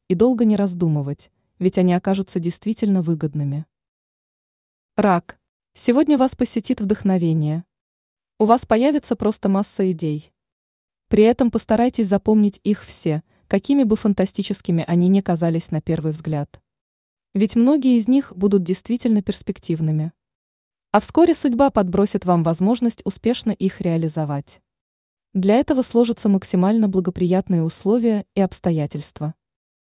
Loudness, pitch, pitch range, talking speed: -20 LUFS, 200 Hz, 170-225 Hz, 120 wpm